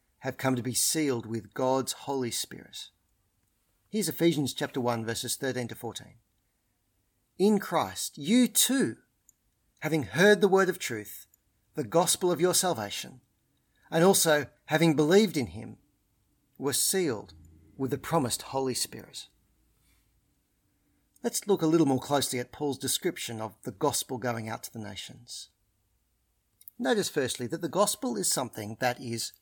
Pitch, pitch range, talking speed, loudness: 135 Hz, 115-165 Hz, 145 wpm, -28 LUFS